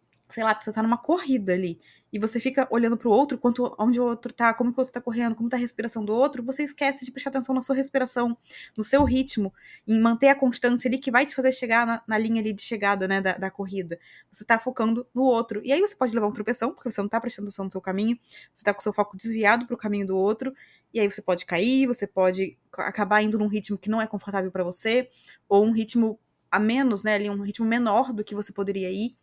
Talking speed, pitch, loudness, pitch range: 260 wpm, 225 Hz, -25 LUFS, 205-245 Hz